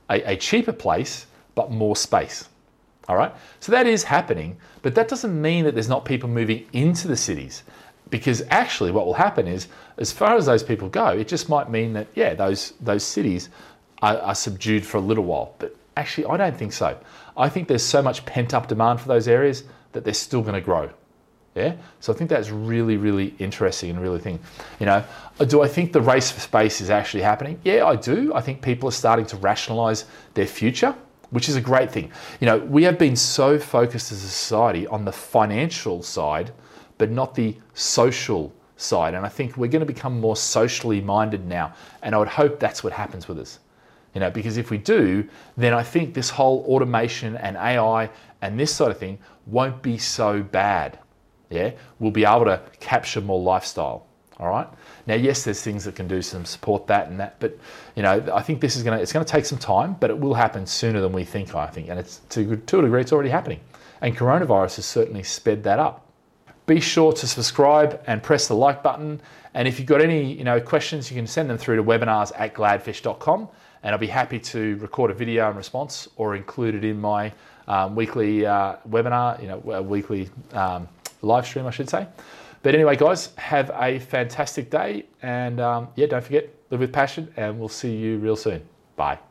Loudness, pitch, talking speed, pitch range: -22 LUFS, 115 Hz, 215 wpm, 105-135 Hz